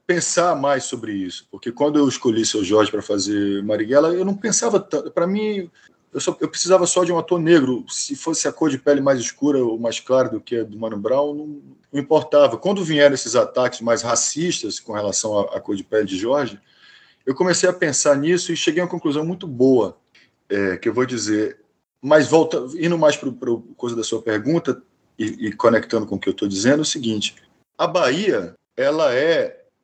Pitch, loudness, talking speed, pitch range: 145 Hz, -20 LUFS, 210 wpm, 115-170 Hz